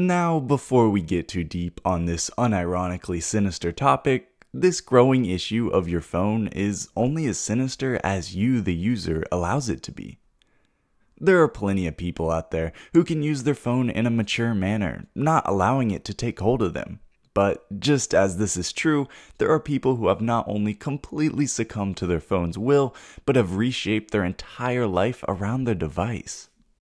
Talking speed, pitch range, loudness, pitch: 180 wpm, 90-130 Hz, -24 LUFS, 110 Hz